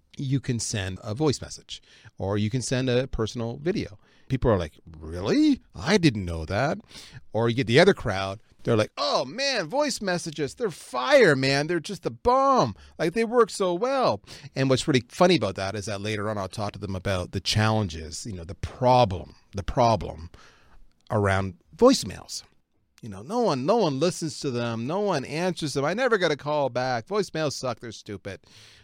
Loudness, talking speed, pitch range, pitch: -25 LUFS, 195 wpm, 100-160 Hz, 120 Hz